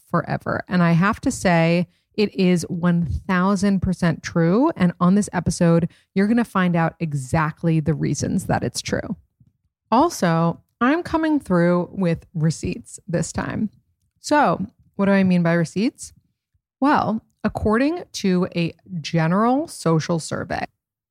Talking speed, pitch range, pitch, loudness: 135 wpm, 170-210 Hz, 180 Hz, -21 LUFS